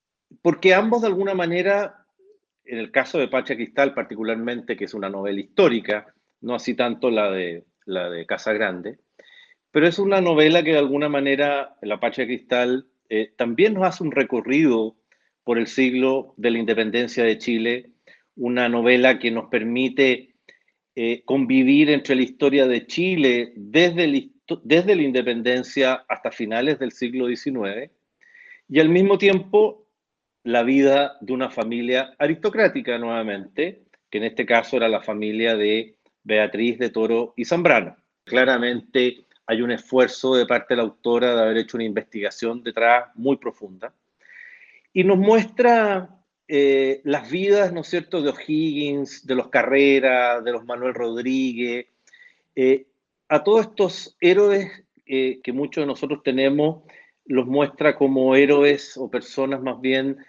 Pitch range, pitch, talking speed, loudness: 120-160 Hz, 130 Hz, 150 wpm, -21 LUFS